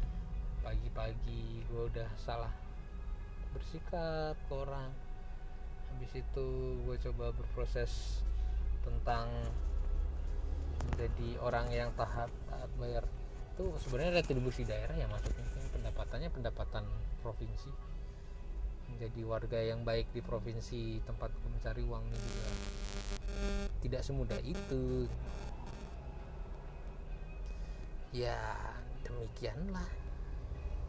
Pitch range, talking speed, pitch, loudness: 75-120 Hz, 85 wpm, 110 Hz, -41 LUFS